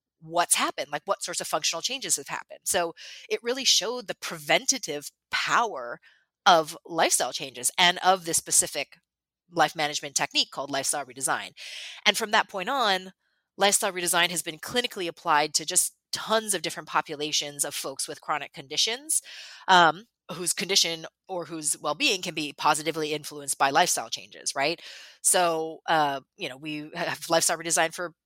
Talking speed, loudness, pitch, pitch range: 160 wpm, -25 LUFS, 165 Hz, 150-185 Hz